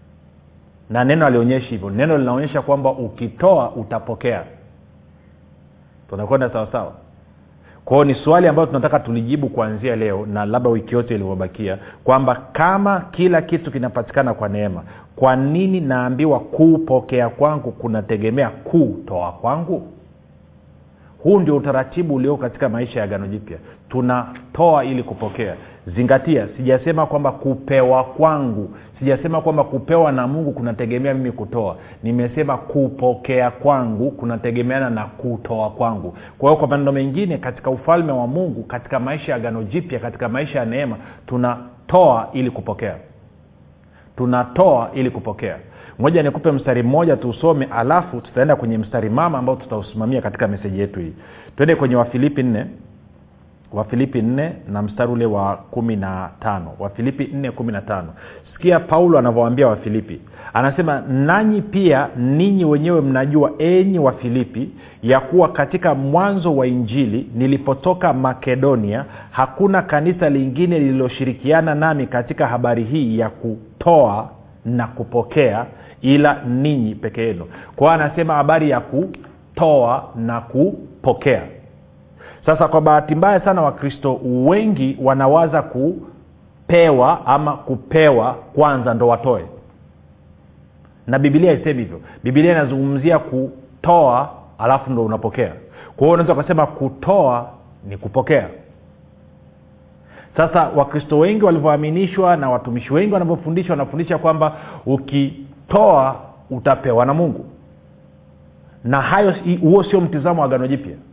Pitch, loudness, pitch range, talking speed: 130 Hz, -17 LUFS, 110-150 Hz, 125 wpm